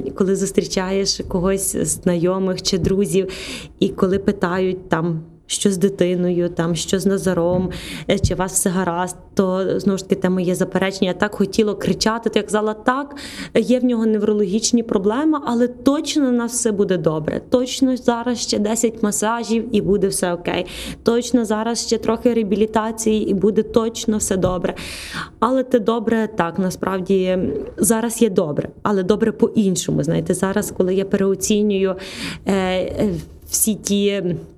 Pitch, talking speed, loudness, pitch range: 205 Hz, 150 wpm, -19 LUFS, 190-225 Hz